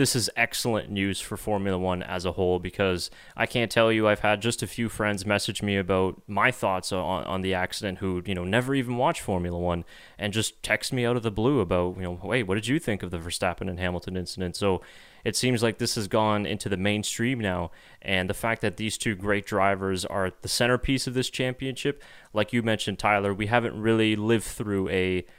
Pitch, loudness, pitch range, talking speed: 105 Hz, -26 LUFS, 95-115 Hz, 225 wpm